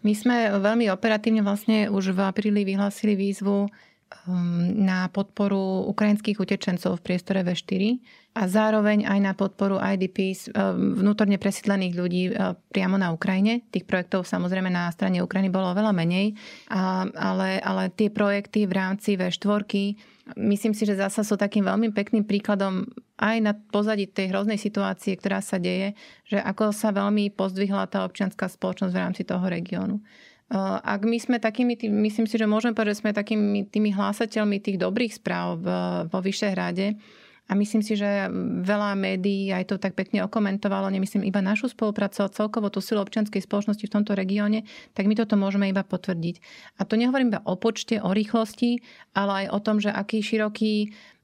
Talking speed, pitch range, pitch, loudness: 165 wpm, 195-215 Hz, 200 Hz, -25 LUFS